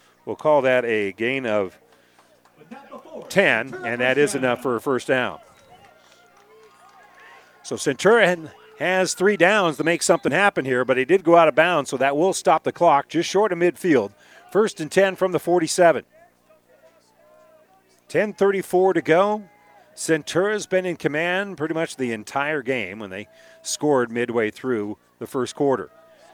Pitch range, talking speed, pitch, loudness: 130-190 Hz, 155 wpm, 165 Hz, -21 LUFS